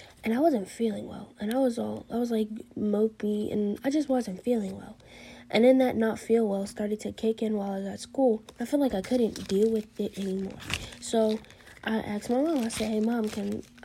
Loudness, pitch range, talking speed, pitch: -28 LUFS, 210-240 Hz, 230 wpm, 220 Hz